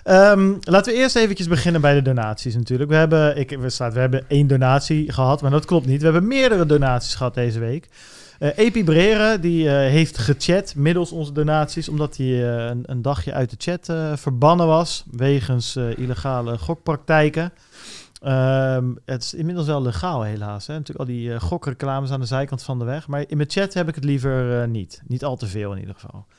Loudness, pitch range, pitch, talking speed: -20 LUFS, 125-160 Hz, 140 Hz, 205 wpm